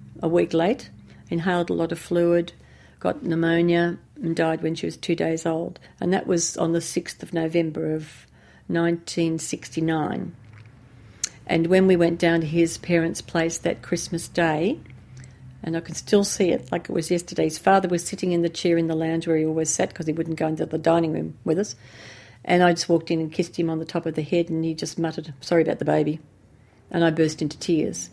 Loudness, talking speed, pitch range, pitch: -24 LUFS, 215 wpm, 160-170 Hz, 165 Hz